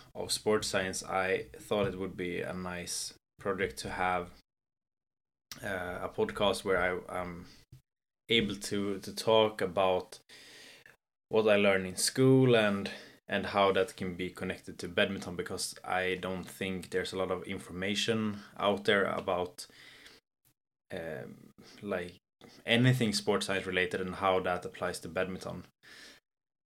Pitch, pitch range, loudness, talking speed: 95 Hz, 90-105 Hz, -32 LUFS, 140 wpm